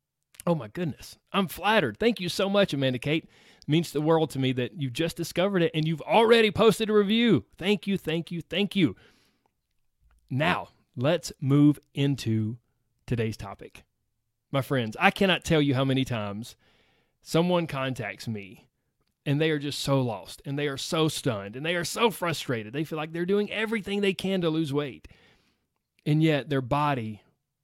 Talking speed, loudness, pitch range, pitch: 180 wpm, -26 LUFS, 130-180 Hz, 155 Hz